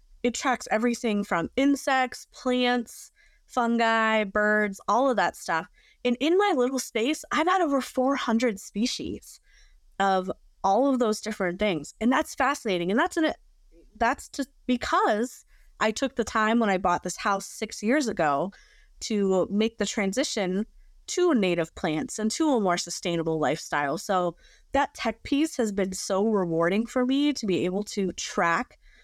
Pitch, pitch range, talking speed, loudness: 225 Hz, 195-260 Hz, 160 wpm, -26 LUFS